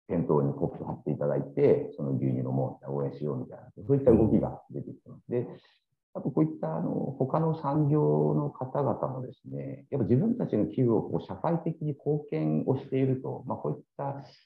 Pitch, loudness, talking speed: 80 Hz, -29 LUFS, 405 characters per minute